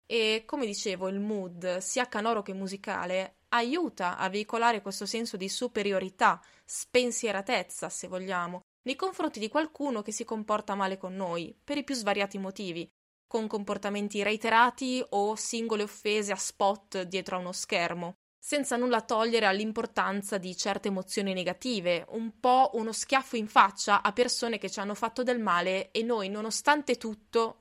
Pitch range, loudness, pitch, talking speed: 195-235 Hz, -30 LUFS, 210 Hz, 155 wpm